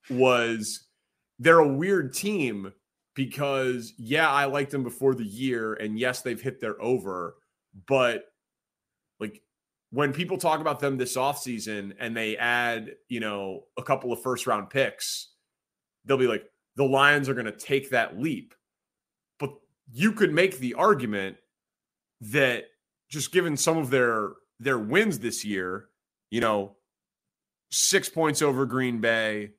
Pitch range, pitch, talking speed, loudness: 115-145 Hz, 130 Hz, 150 wpm, -26 LUFS